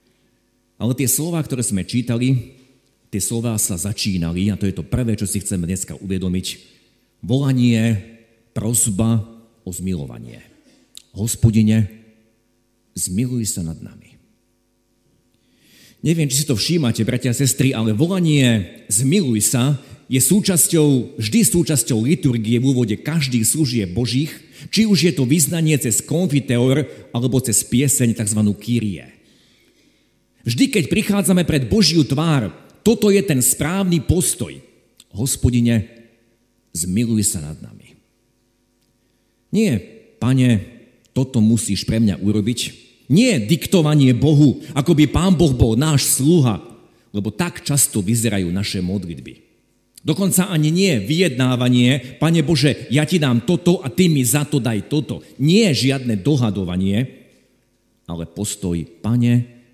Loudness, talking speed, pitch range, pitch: -18 LUFS, 125 wpm, 110-145 Hz, 120 Hz